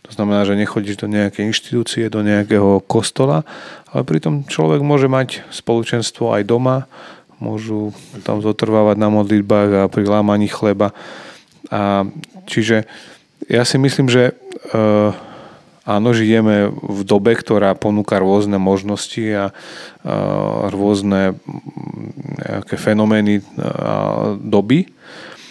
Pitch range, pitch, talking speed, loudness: 100-115 Hz, 105 Hz, 115 wpm, -16 LUFS